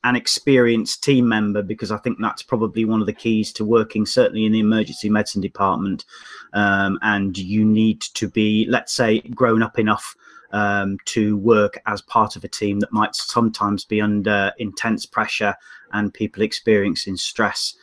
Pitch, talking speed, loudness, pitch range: 110 Hz, 170 wpm, -20 LUFS, 105-110 Hz